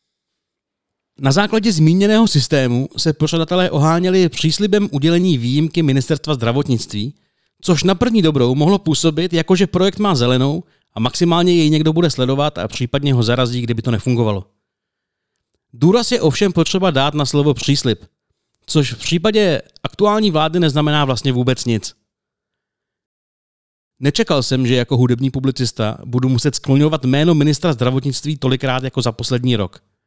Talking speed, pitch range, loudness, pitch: 140 wpm, 125-170 Hz, -16 LUFS, 145 Hz